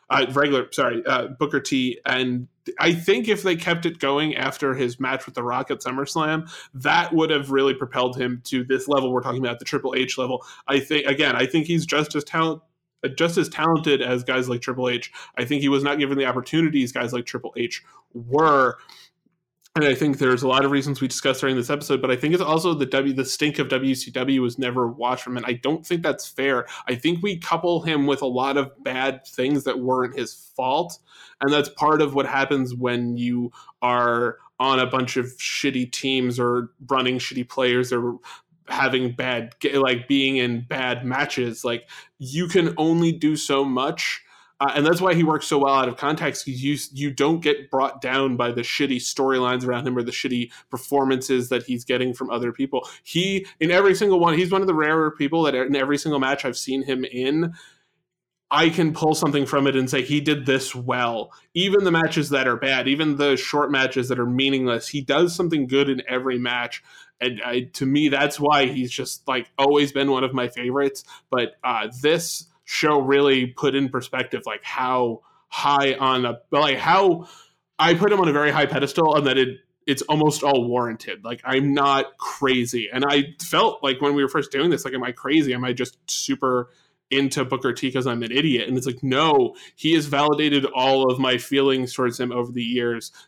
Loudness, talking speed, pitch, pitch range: -22 LUFS, 210 wpm, 135 Hz, 125-150 Hz